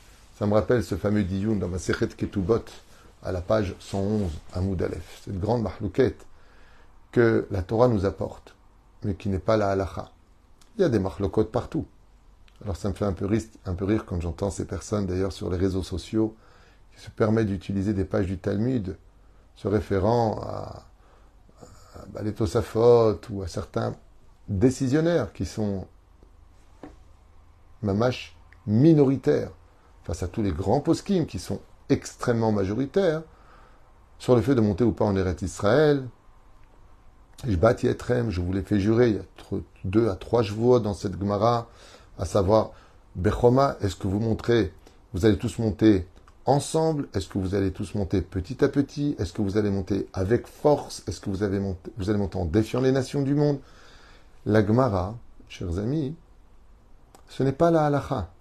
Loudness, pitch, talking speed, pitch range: -25 LUFS, 100 Hz, 170 wpm, 95-115 Hz